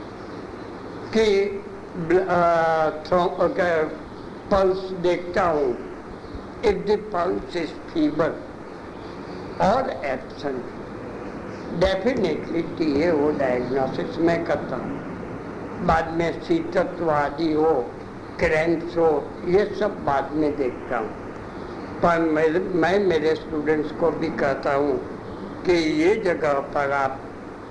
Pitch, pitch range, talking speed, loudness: 170 Hz, 155-190 Hz, 95 wpm, -23 LUFS